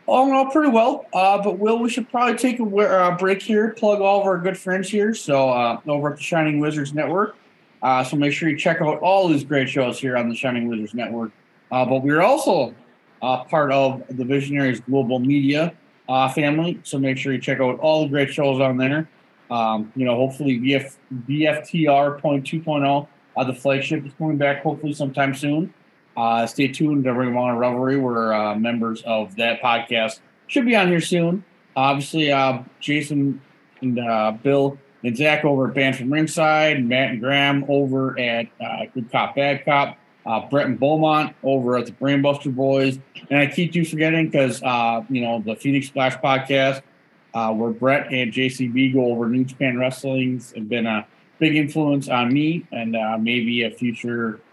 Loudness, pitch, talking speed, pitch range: -20 LUFS, 140 Hz, 195 wpm, 125-155 Hz